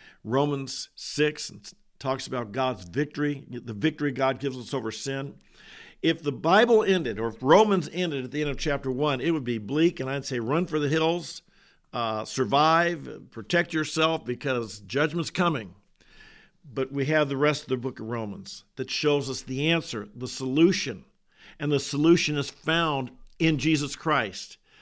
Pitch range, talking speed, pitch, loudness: 130-160 Hz, 170 wpm, 145 Hz, -26 LUFS